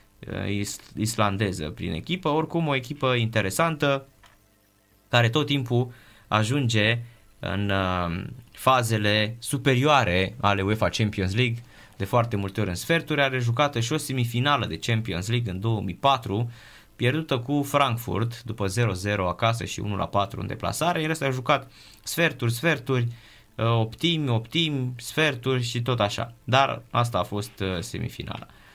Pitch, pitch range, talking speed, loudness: 115 Hz, 105-135 Hz, 125 wpm, -25 LUFS